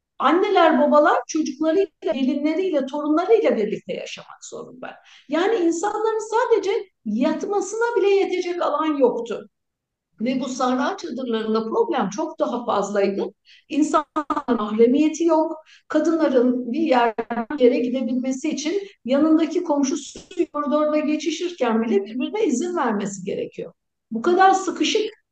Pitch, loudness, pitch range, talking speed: 310 Hz, -21 LUFS, 260-370 Hz, 110 wpm